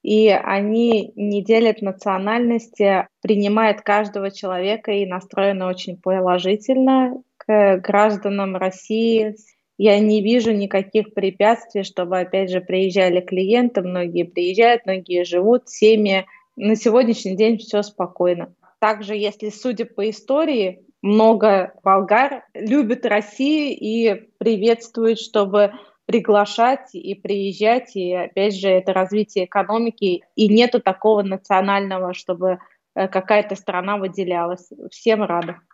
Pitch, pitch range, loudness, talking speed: 205 Hz, 190-225 Hz, -19 LUFS, 110 wpm